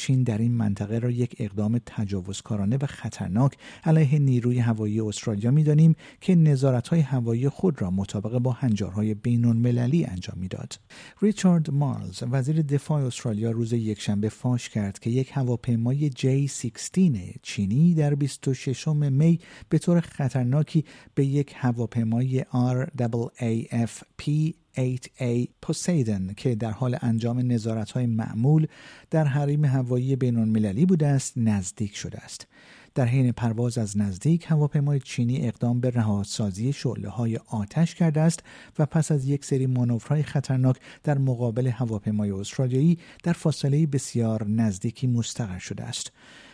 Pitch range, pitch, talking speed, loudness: 115-145 Hz, 125 Hz, 135 wpm, -25 LUFS